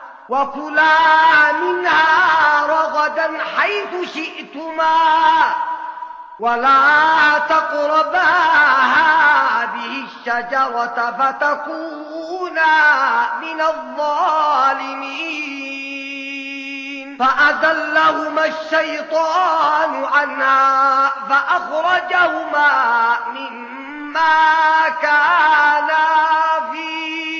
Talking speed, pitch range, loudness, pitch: 40 wpm, 290-325 Hz, -15 LUFS, 315 Hz